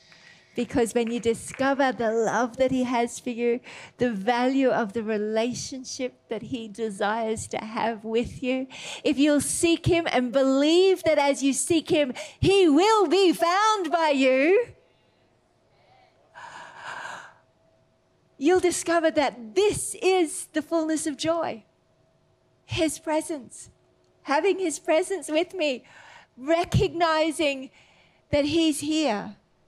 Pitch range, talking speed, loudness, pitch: 245-335 Hz, 120 wpm, -24 LUFS, 295 Hz